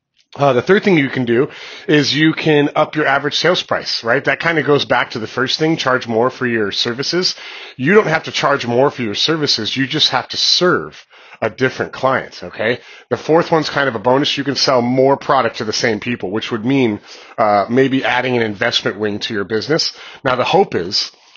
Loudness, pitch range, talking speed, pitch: -15 LUFS, 120-145 Hz, 225 wpm, 130 Hz